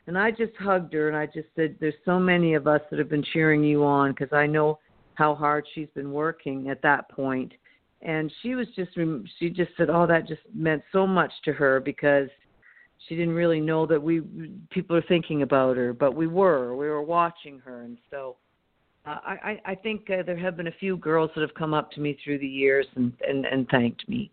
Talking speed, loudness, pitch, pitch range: 225 wpm, -25 LUFS, 155 Hz, 145-170 Hz